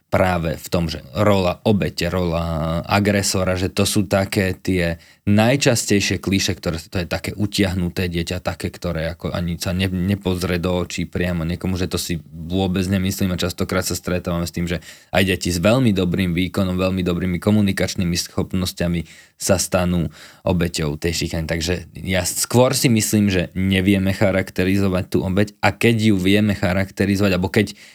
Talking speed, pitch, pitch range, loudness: 160 wpm, 95 Hz, 85-100 Hz, -20 LUFS